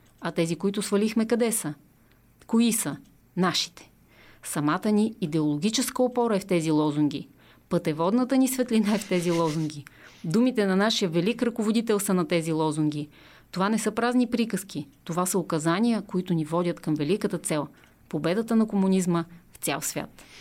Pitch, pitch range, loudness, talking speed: 185 Hz, 165-220 Hz, -26 LUFS, 155 wpm